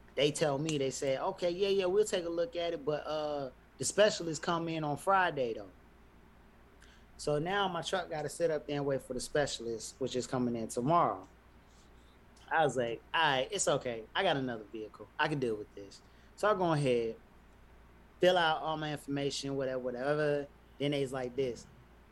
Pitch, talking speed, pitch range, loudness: 145 Hz, 195 wpm, 130-170 Hz, -33 LUFS